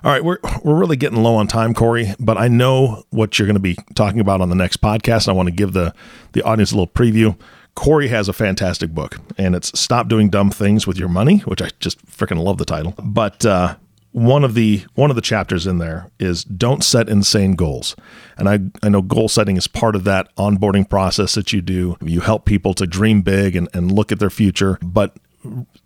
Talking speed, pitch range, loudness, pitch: 230 wpm, 95-115 Hz, -16 LUFS, 105 Hz